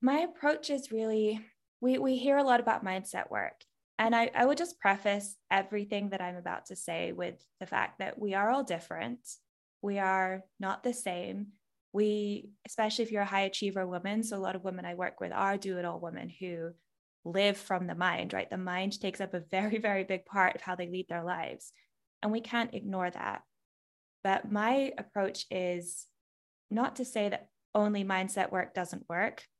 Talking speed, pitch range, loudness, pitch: 195 wpm, 185-225 Hz, -33 LUFS, 200 Hz